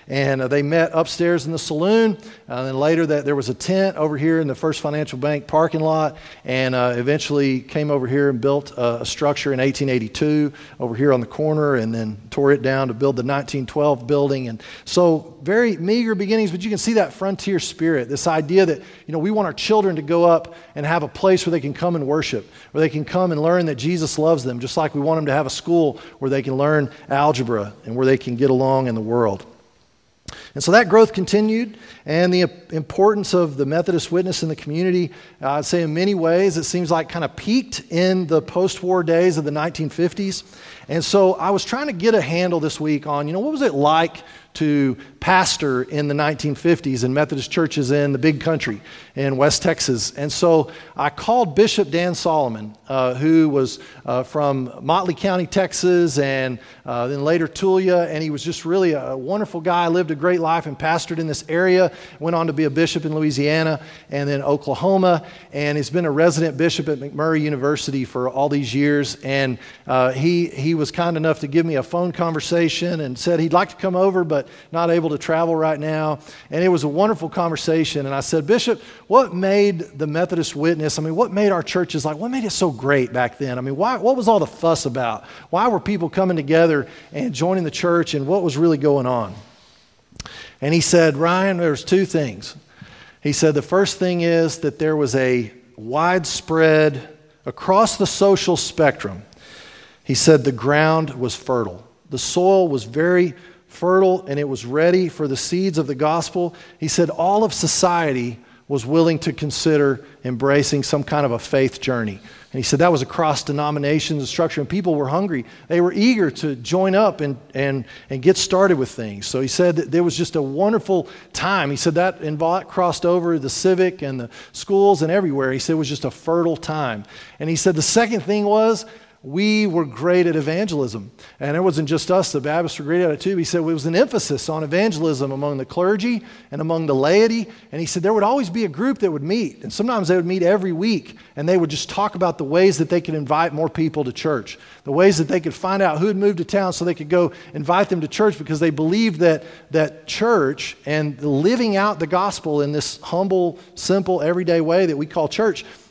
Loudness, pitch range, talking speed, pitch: -19 LUFS, 145-180 Hz, 215 wpm, 160 Hz